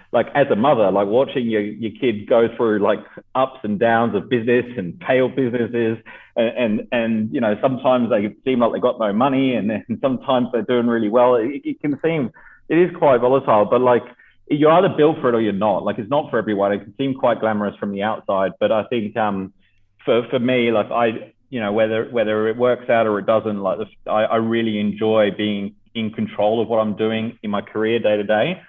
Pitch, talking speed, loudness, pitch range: 115 Hz, 230 wpm, -19 LUFS, 105-125 Hz